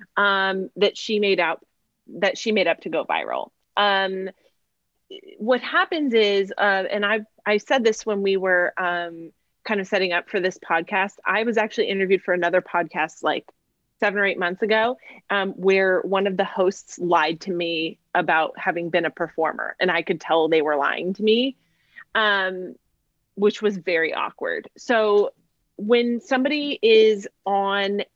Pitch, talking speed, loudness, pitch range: 195 Hz, 170 wpm, -22 LUFS, 180-220 Hz